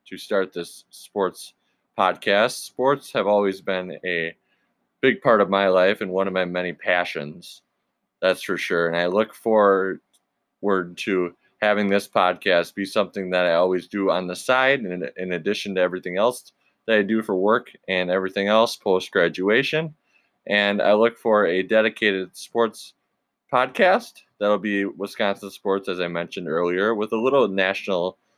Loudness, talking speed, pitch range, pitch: -22 LUFS, 165 wpm, 90-105 Hz, 95 Hz